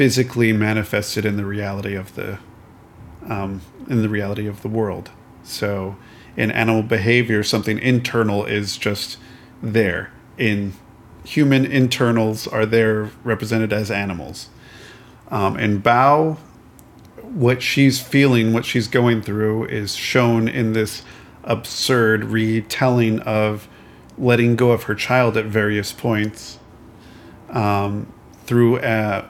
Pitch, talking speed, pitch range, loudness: 110 Hz, 120 wpm, 105-120 Hz, -19 LUFS